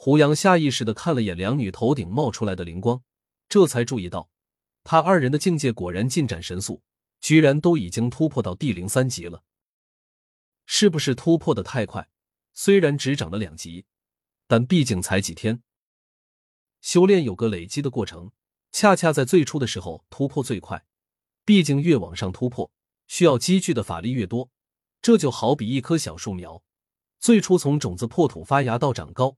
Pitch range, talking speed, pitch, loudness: 95-150 Hz, 260 characters per minute, 120 Hz, -22 LUFS